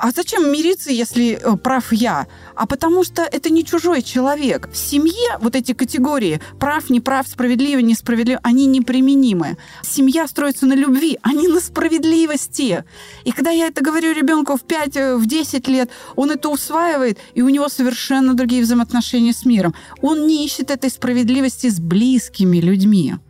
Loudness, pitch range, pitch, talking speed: -16 LUFS, 245-300 Hz, 265 Hz, 165 wpm